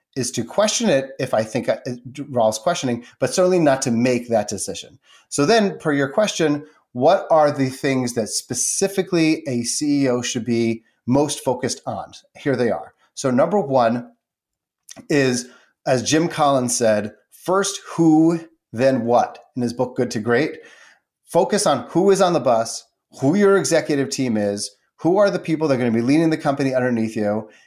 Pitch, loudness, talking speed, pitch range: 135 Hz, -20 LUFS, 175 wpm, 120-165 Hz